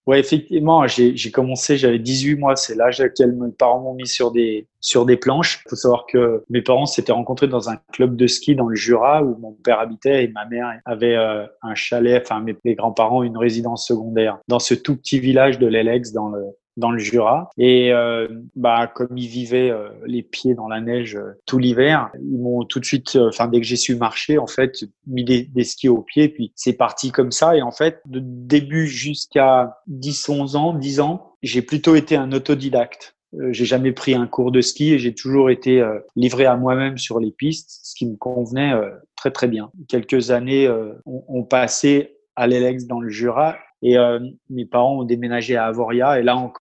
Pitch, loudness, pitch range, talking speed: 125 Hz, -18 LUFS, 120-135 Hz, 220 wpm